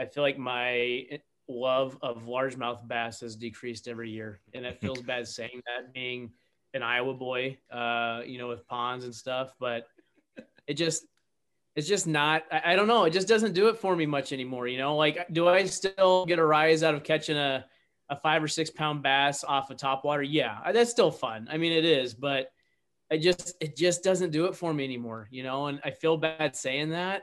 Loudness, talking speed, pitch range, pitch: -28 LUFS, 210 wpm, 125-160 Hz, 140 Hz